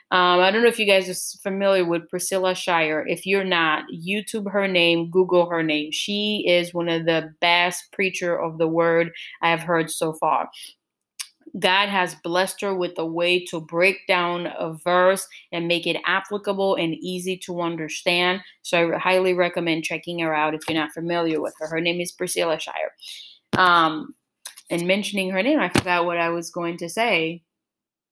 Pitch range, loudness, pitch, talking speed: 165-185 Hz, -22 LUFS, 175 Hz, 185 wpm